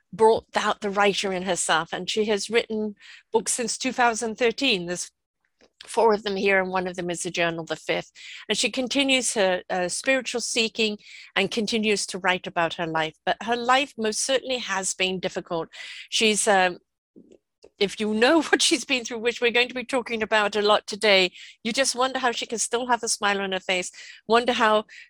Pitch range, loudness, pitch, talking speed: 190-240 Hz, -23 LUFS, 215 Hz, 200 wpm